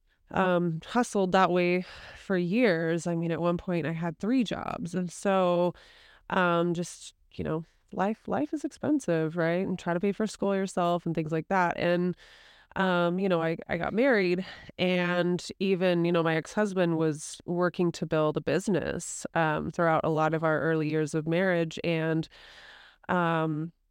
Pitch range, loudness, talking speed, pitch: 165-190 Hz, -28 LUFS, 175 wpm, 175 Hz